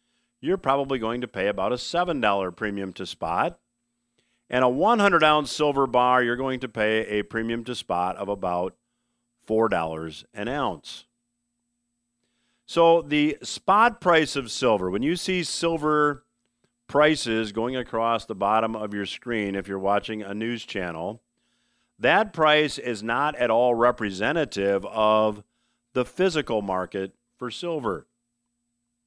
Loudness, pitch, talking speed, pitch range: -24 LUFS, 120 Hz, 140 wpm, 110-140 Hz